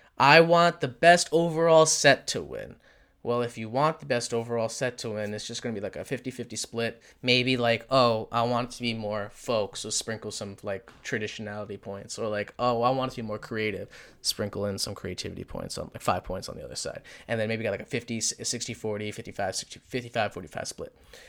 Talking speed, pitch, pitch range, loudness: 210 wpm, 115 Hz, 105-125 Hz, -27 LUFS